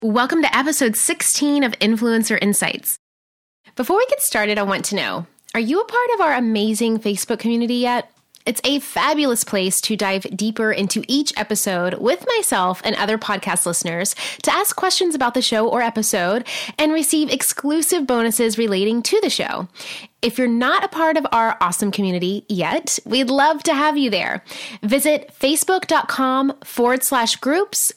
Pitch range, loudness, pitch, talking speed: 210-290 Hz, -18 LUFS, 240 Hz, 165 wpm